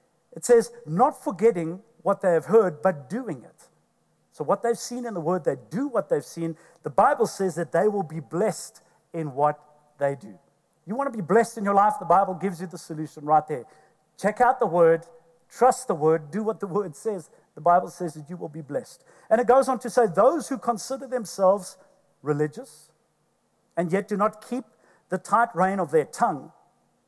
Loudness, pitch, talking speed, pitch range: -24 LUFS, 190 Hz, 205 wpm, 165-235 Hz